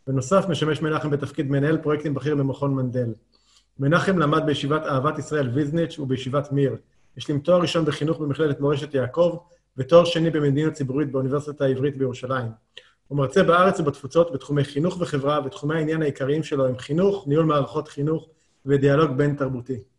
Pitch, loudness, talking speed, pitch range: 145 Hz, -23 LUFS, 150 wpm, 135-160 Hz